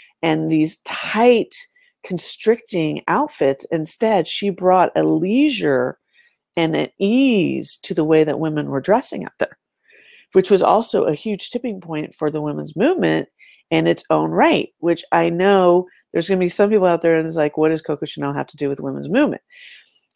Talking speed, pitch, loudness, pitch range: 180 wpm, 175 Hz, -18 LUFS, 155-225 Hz